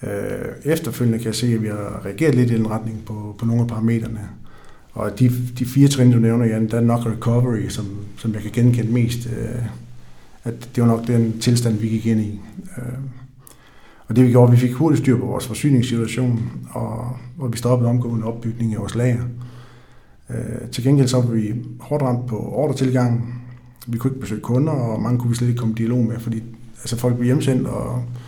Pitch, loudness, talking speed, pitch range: 120 Hz, -20 LUFS, 215 wpm, 115-125 Hz